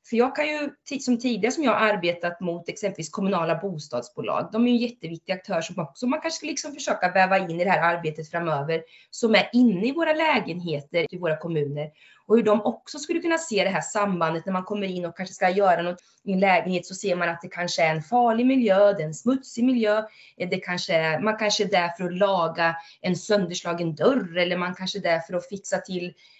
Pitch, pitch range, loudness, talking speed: 190 Hz, 170-230 Hz, -24 LUFS, 230 wpm